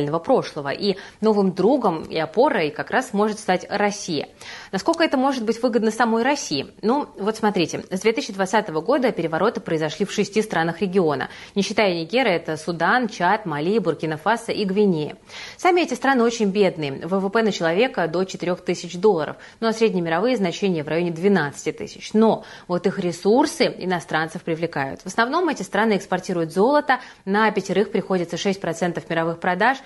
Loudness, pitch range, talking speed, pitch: -22 LUFS, 170-225 Hz, 160 wpm, 195 Hz